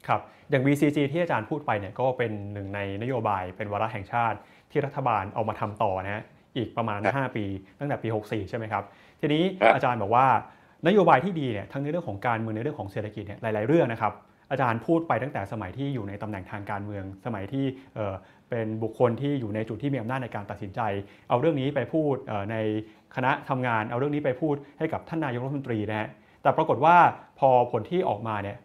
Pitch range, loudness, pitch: 105-135 Hz, -27 LUFS, 115 Hz